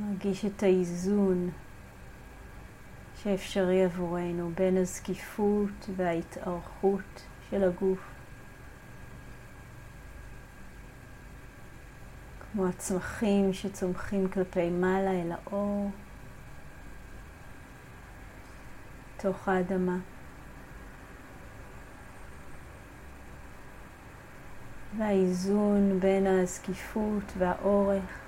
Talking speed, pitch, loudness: 50 wpm, 185 Hz, -30 LUFS